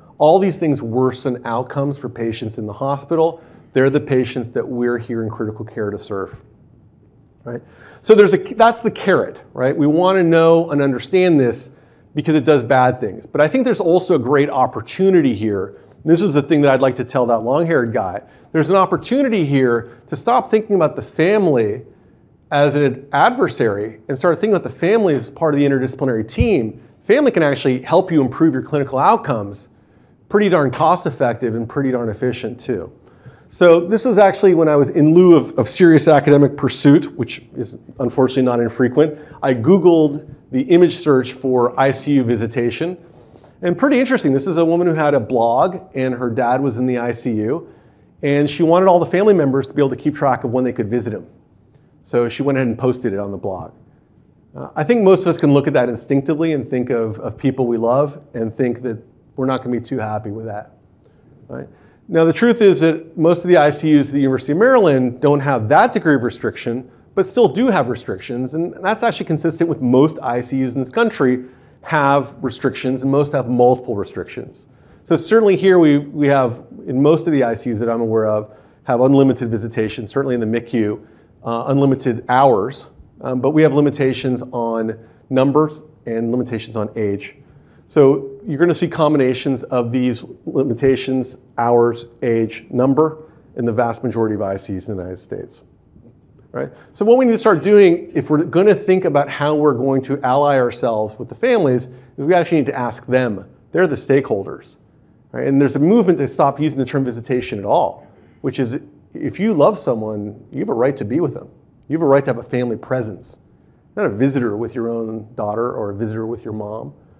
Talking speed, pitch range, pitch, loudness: 200 wpm, 120-155 Hz, 135 Hz, -16 LUFS